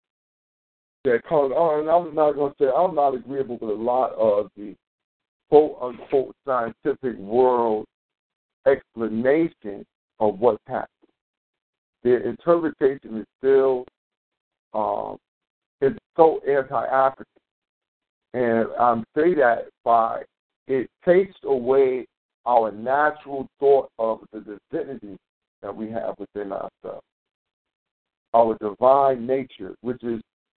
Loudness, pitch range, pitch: -22 LUFS, 115-150 Hz, 130 Hz